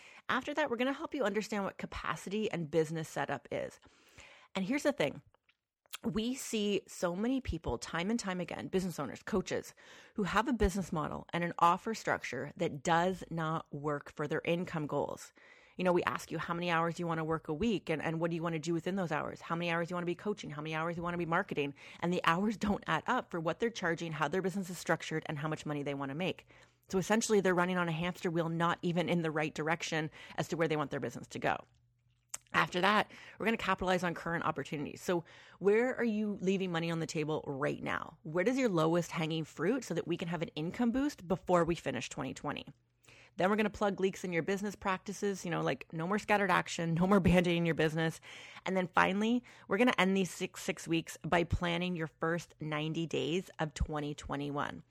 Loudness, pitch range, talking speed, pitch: -34 LUFS, 160-195 Hz, 225 wpm, 175 Hz